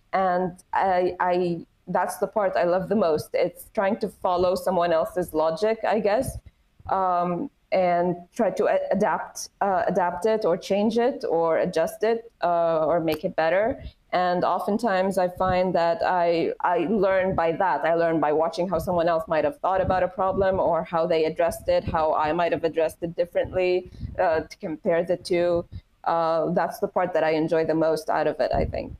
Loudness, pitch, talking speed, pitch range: -24 LUFS, 175 Hz, 190 wpm, 165-185 Hz